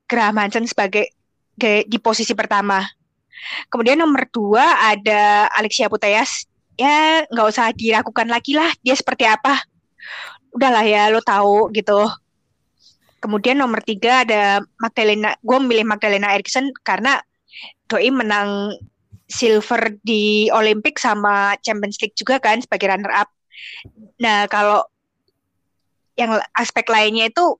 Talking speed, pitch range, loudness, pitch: 120 wpm, 210-240 Hz, -16 LUFS, 220 Hz